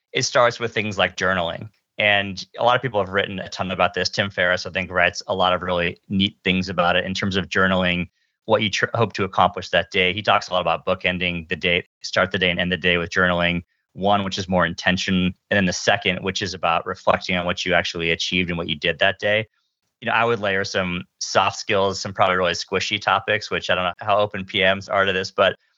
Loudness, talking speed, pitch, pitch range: -21 LUFS, 250 wpm, 95 Hz, 90-100 Hz